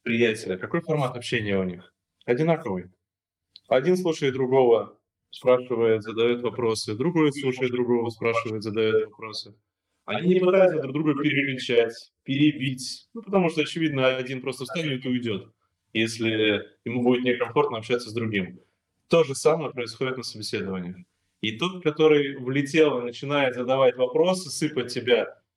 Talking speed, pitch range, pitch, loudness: 135 wpm, 110-150 Hz, 125 Hz, -24 LUFS